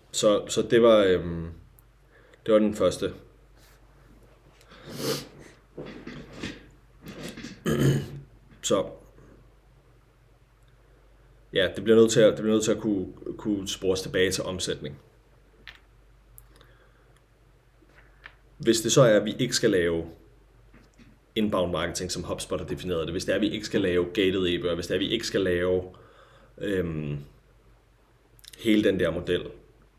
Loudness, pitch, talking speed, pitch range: -25 LUFS, 105 Hz, 130 wpm, 90-115 Hz